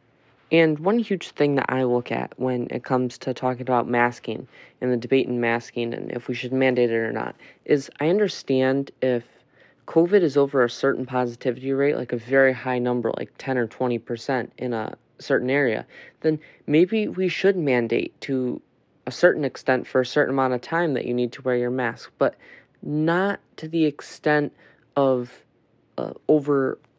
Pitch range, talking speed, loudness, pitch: 125-145 Hz, 180 wpm, -23 LUFS, 130 Hz